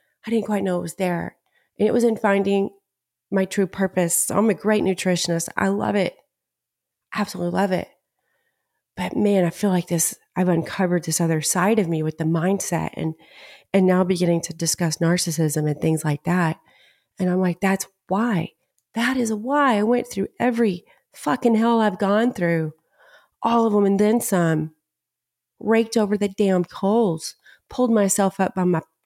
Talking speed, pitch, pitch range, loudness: 180 wpm, 190 Hz, 170-210 Hz, -21 LUFS